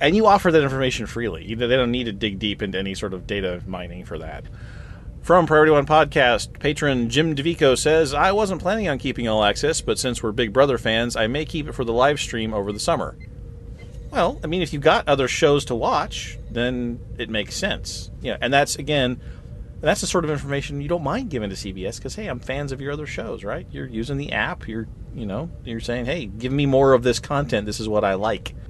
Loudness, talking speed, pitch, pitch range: -21 LUFS, 235 wpm, 125 Hz, 110-145 Hz